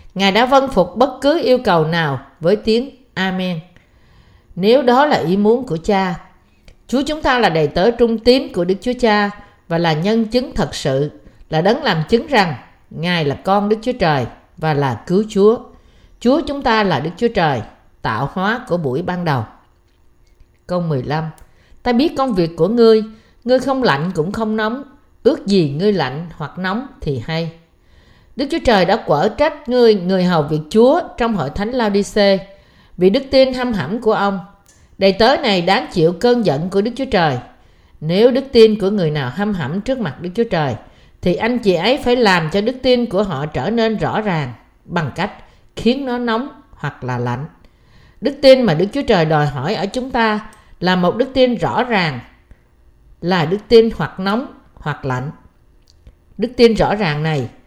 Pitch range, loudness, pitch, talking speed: 160-240 Hz, -16 LUFS, 200 Hz, 190 wpm